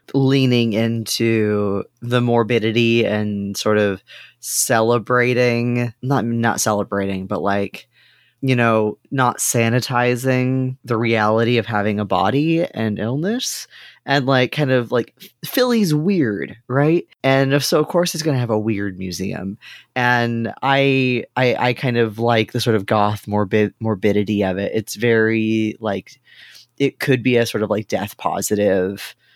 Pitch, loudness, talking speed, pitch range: 115 Hz, -18 LUFS, 145 wpm, 105-130 Hz